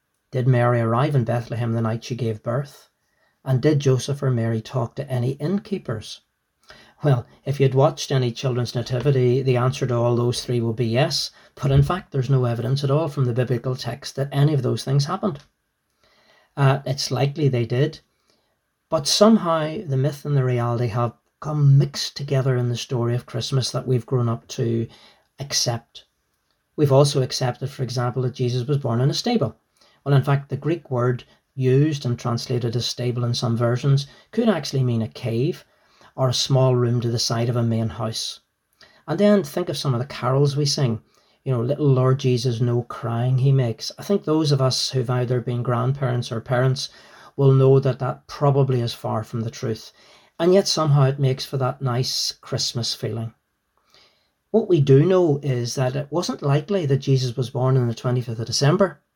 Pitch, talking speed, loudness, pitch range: 130 Hz, 195 wpm, -22 LUFS, 120-140 Hz